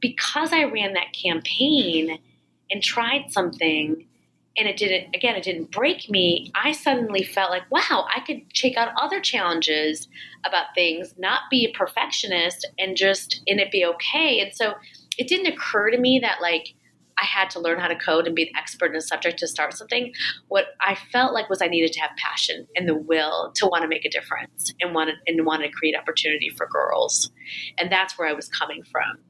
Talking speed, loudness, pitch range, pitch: 205 wpm, -22 LUFS, 165-245 Hz, 190 Hz